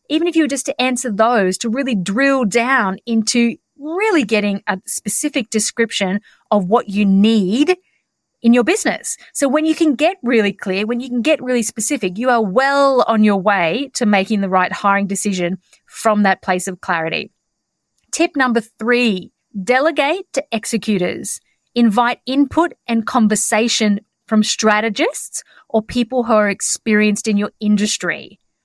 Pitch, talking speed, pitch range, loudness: 230 Hz, 155 wpm, 205-260 Hz, -16 LUFS